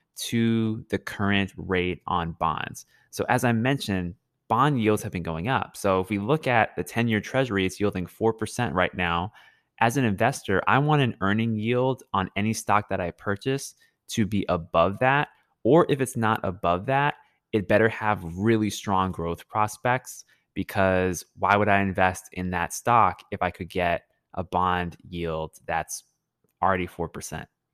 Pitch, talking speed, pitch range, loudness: 100 Hz, 170 wpm, 90-115 Hz, -25 LUFS